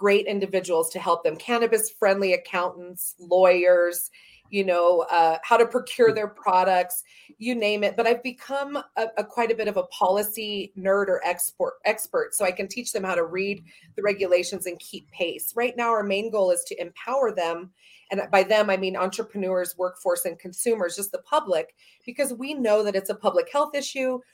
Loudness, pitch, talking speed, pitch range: -24 LUFS, 200 Hz, 190 wpm, 180-235 Hz